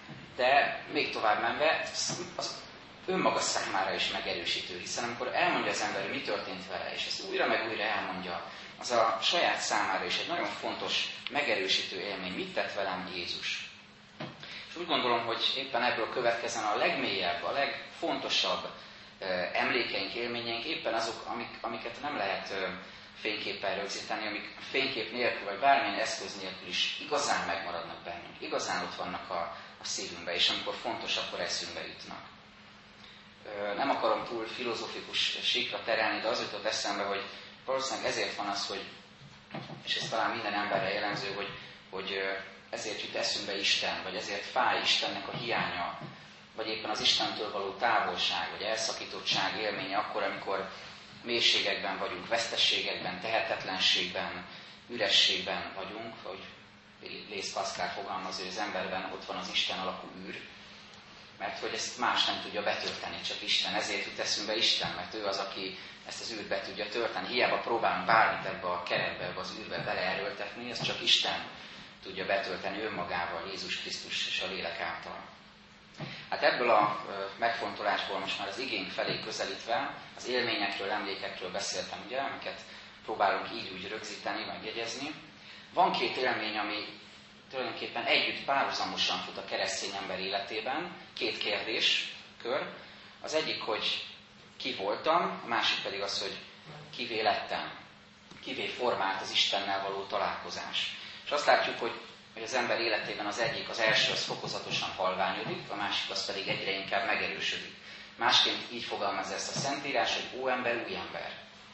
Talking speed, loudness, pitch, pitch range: 150 wpm, -31 LUFS, 100 Hz, 95-115 Hz